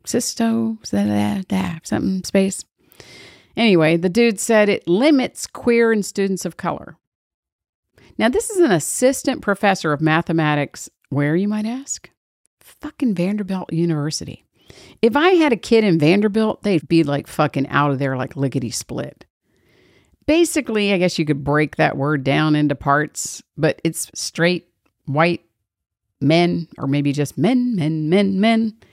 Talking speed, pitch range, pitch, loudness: 150 wpm, 150-220 Hz, 175 Hz, -19 LUFS